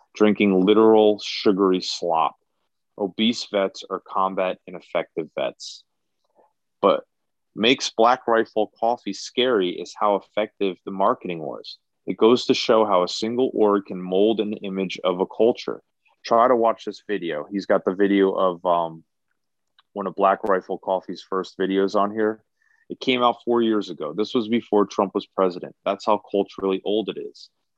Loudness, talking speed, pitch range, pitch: -22 LUFS, 160 wpm, 95-110 Hz, 100 Hz